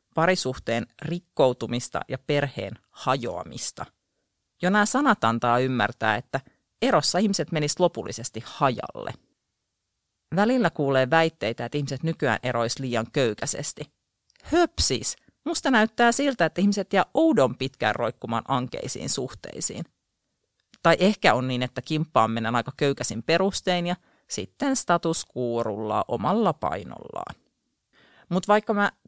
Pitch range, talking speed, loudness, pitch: 120-190 Hz, 115 wpm, -24 LUFS, 150 Hz